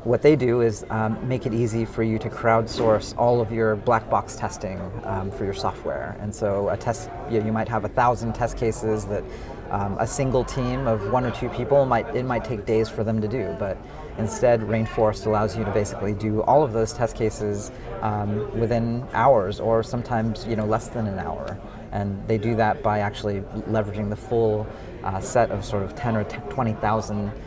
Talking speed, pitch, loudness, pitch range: 210 wpm, 110 Hz, -24 LUFS, 105-115 Hz